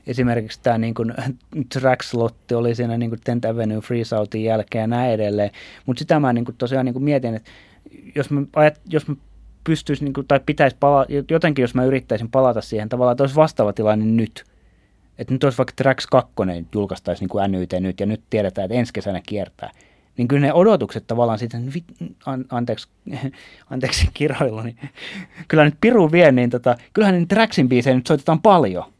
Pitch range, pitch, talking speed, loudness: 110-140 Hz, 125 Hz, 185 wpm, -19 LUFS